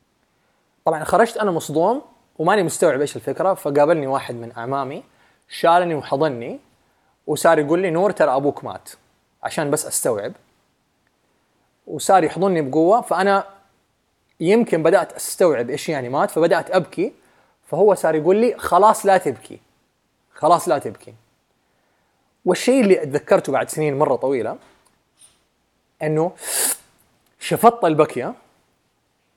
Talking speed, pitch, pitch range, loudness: 115 wpm, 165 Hz, 145-195 Hz, -19 LUFS